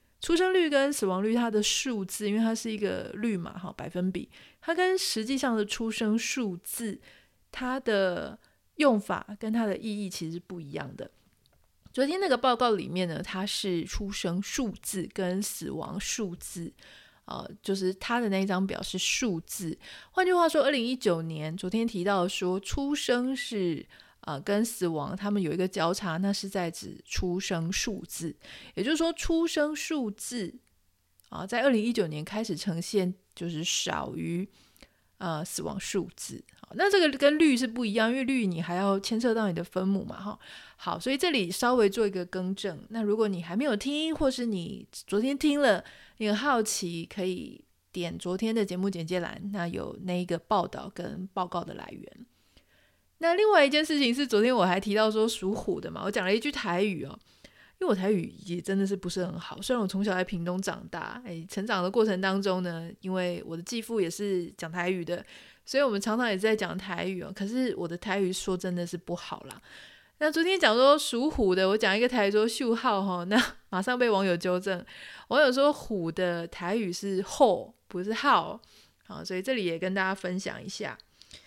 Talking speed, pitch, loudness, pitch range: 275 characters per minute, 200 Hz, -29 LUFS, 180-235 Hz